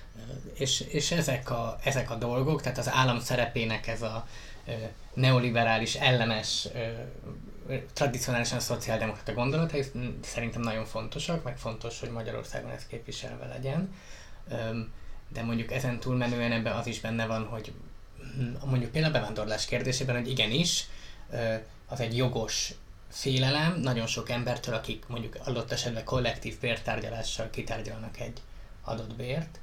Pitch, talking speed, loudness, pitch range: 120 Hz, 125 wpm, -31 LUFS, 110-130 Hz